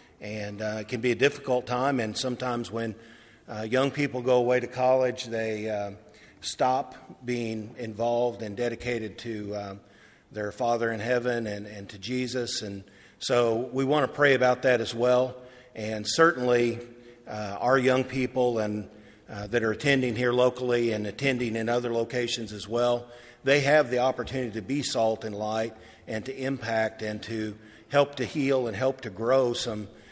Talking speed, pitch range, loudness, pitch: 175 wpm, 110-125 Hz, -27 LUFS, 120 Hz